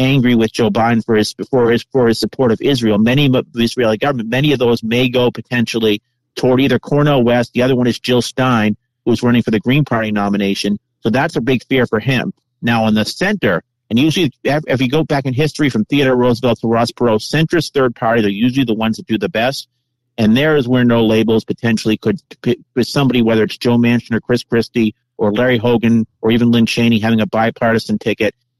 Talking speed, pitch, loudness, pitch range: 220 wpm, 120 Hz, -15 LUFS, 110-130 Hz